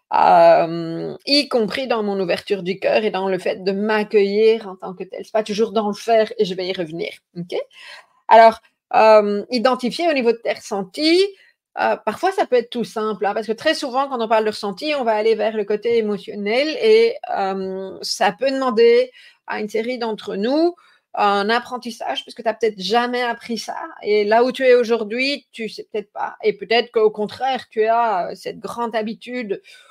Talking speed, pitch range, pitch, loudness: 205 wpm, 210-265 Hz, 230 Hz, -19 LUFS